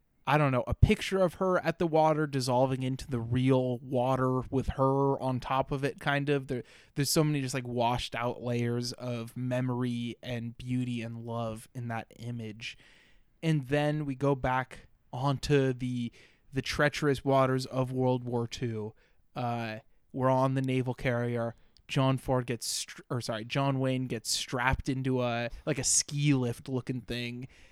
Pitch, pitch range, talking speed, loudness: 130 Hz, 120-140 Hz, 170 wpm, -30 LUFS